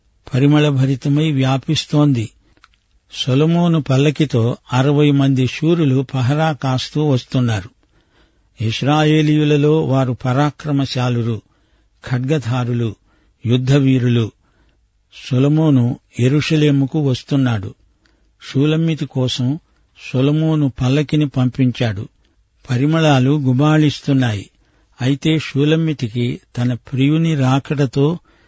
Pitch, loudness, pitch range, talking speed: 135 Hz, -16 LUFS, 120-150 Hz, 65 wpm